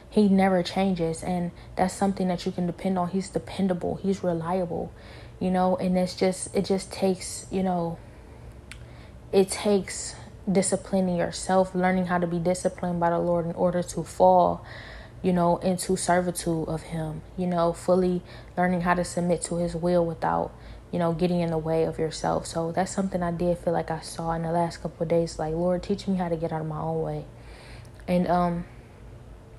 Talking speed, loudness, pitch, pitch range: 195 wpm, -26 LUFS, 175 Hz, 165-185 Hz